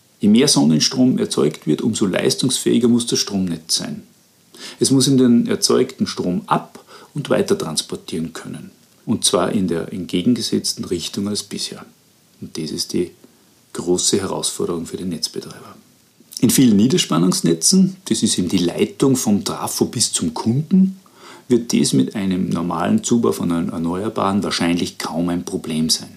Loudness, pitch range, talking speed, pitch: -18 LUFS, 85-125 Hz, 150 wpm, 100 Hz